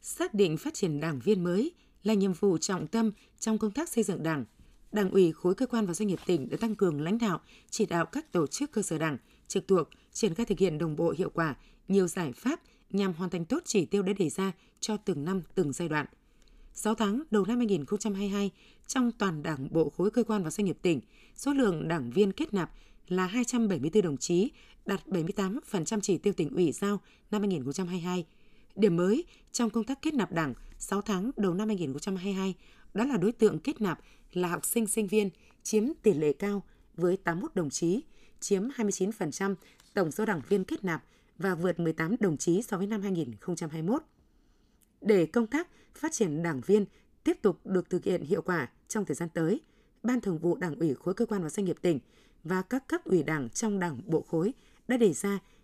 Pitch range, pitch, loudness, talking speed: 175-215 Hz, 195 Hz, -30 LUFS, 210 wpm